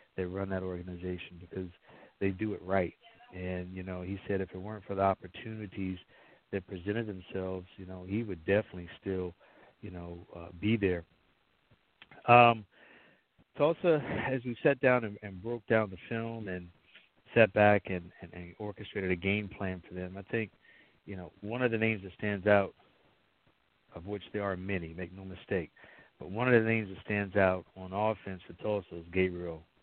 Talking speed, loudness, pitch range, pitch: 185 wpm, -32 LUFS, 90-105 Hz, 95 Hz